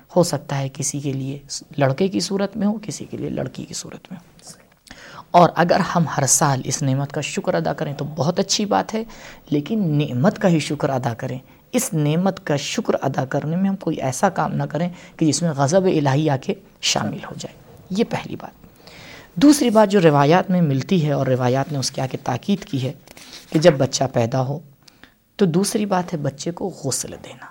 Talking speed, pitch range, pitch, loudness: 215 wpm, 140-185 Hz, 155 Hz, -20 LUFS